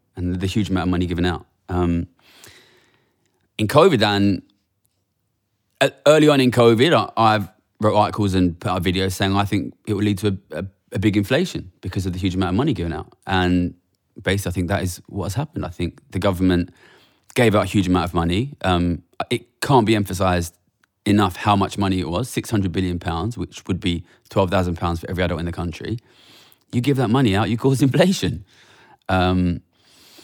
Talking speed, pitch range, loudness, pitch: 190 wpm, 90-105 Hz, -20 LUFS, 95 Hz